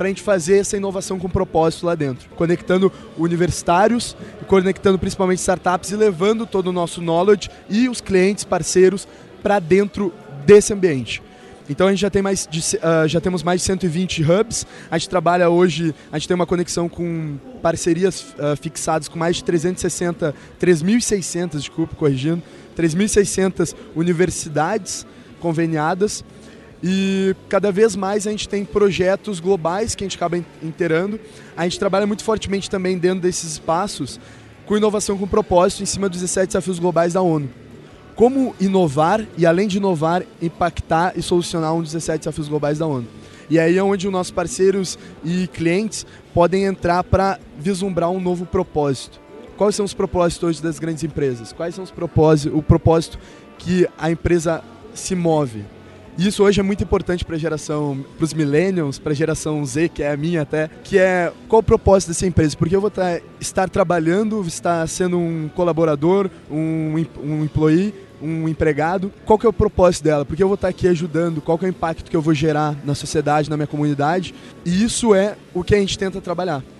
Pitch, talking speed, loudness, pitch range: 175 Hz, 175 wpm, -19 LUFS, 160-195 Hz